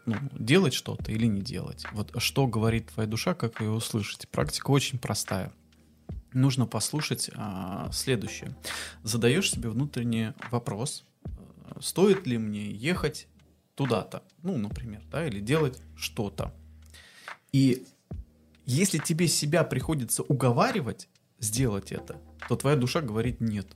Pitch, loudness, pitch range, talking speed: 115 Hz, -28 LUFS, 100-135 Hz, 125 wpm